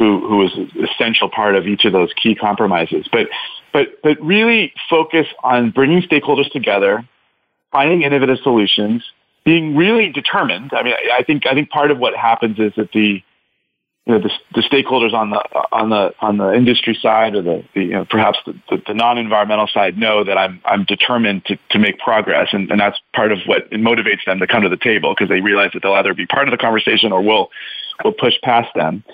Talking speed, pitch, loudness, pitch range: 215 wpm, 115 Hz, -15 LUFS, 105-145 Hz